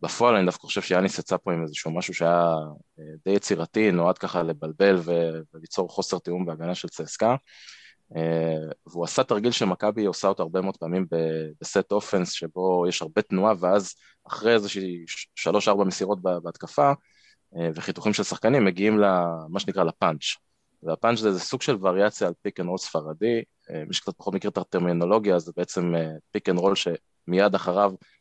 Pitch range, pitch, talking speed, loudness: 85-100 Hz, 90 Hz, 155 wpm, -25 LUFS